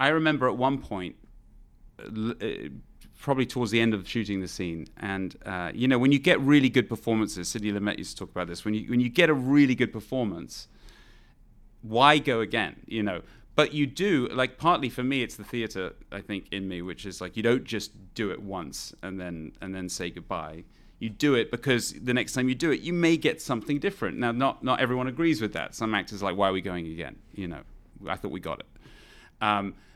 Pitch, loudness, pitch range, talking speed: 115 Hz, -27 LUFS, 95-130 Hz, 225 wpm